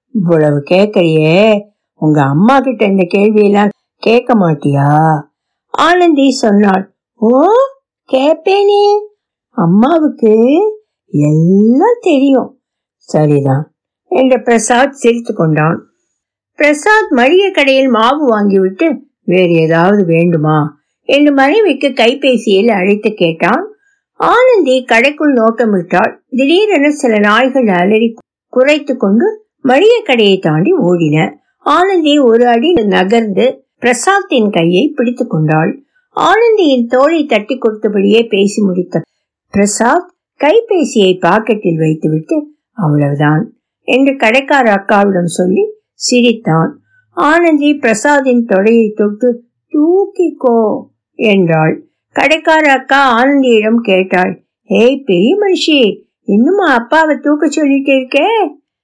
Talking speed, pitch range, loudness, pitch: 90 wpm, 195-295 Hz, -10 LUFS, 235 Hz